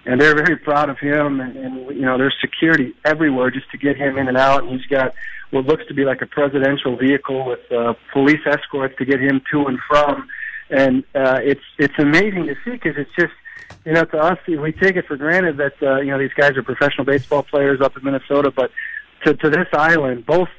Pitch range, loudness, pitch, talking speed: 135-155 Hz, -17 LUFS, 140 Hz, 230 wpm